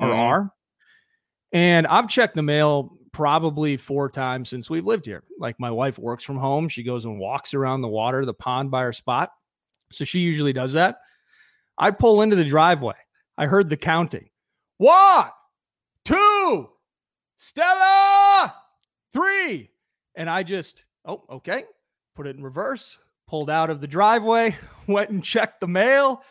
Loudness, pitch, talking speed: -20 LUFS, 165 Hz, 155 wpm